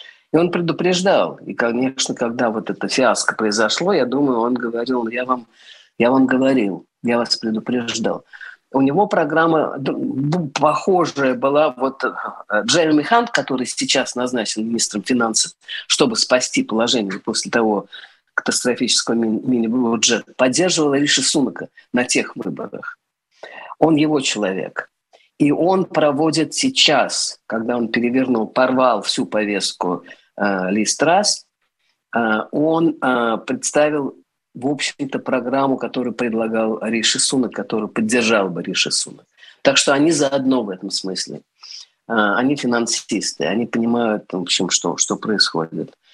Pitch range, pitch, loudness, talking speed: 115-150 Hz, 130 Hz, -18 LUFS, 125 wpm